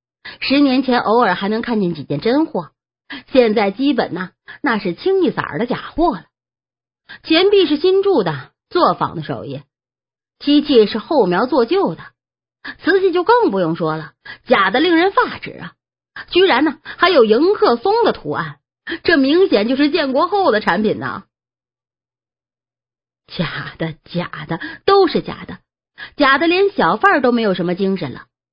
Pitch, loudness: 285 Hz, -16 LUFS